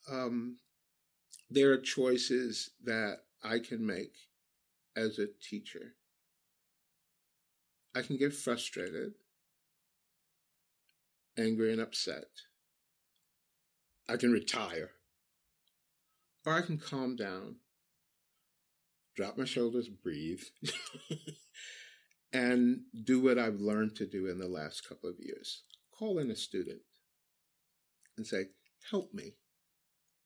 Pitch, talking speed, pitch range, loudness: 135 Hz, 100 wpm, 120-170 Hz, -35 LUFS